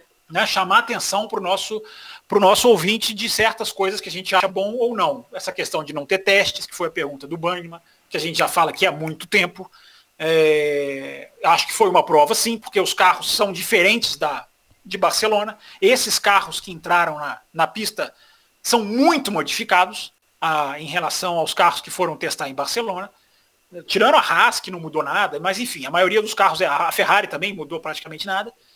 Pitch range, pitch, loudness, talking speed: 165-215 Hz, 190 Hz, -19 LUFS, 195 wpm